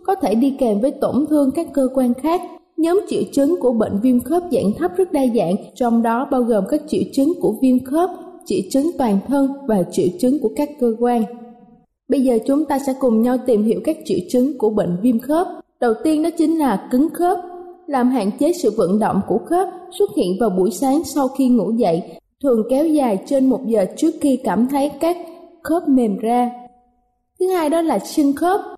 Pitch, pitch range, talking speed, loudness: 270 Hz, 235-320 Hz, 215 wpm, -18 LUFS